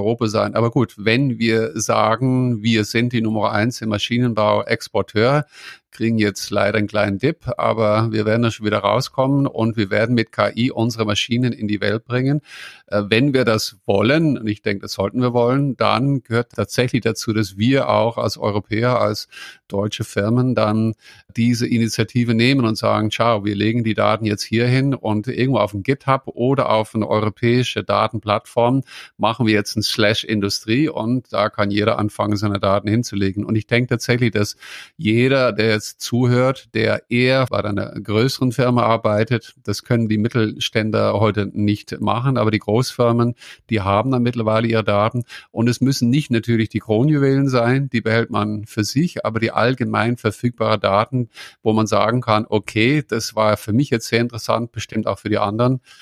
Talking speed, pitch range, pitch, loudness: 180 wpm, 105-120 Hz, 110 Hz, -19 LUFS